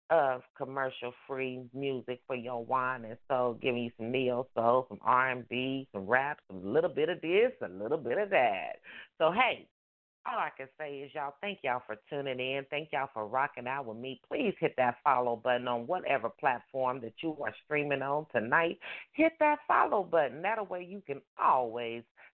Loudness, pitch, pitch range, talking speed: -32 LUFS, 130 Hz, 125-155 Hz, 185 wpm